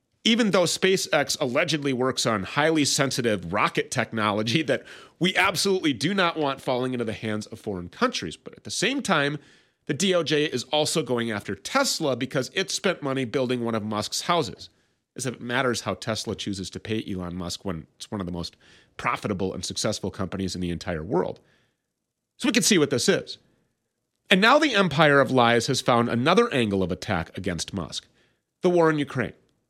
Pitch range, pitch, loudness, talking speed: 105-155 Hz, 125 Hz, -24 LUFS, 190 wpm